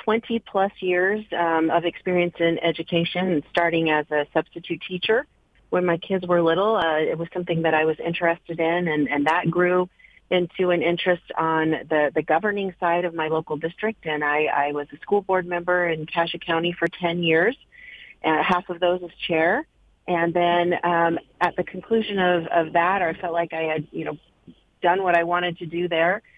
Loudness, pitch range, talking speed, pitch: -23 LUFS, 165-180 Hz, 195 wpm, 170 Hz